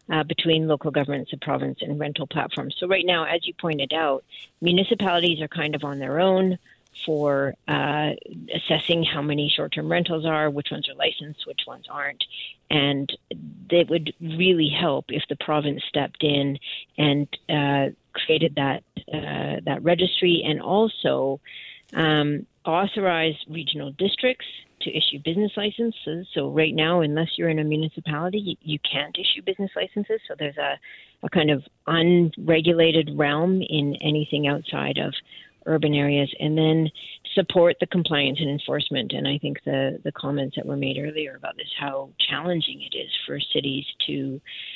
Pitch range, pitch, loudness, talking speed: 145-170 Hz, 155 Hz, -24 LUFS, 160 wpm